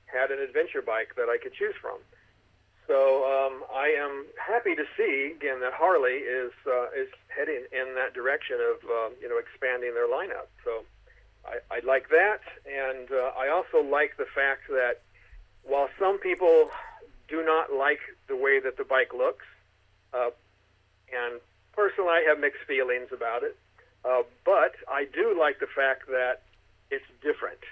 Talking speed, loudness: 165 wpm, -27 LUFS